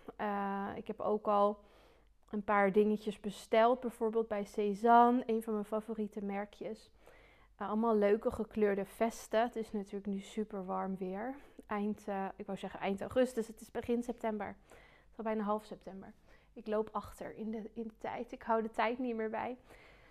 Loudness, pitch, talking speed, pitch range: -35 LUFS, 215 Hz, 180 wpm, 205-225 Hz